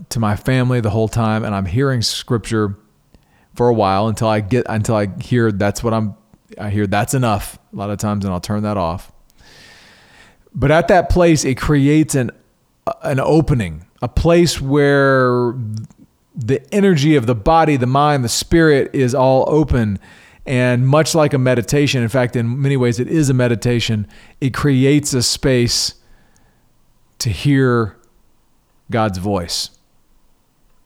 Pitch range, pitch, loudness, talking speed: 105-140 Hz, 120 Hz, -16 LUFS, 160 wpm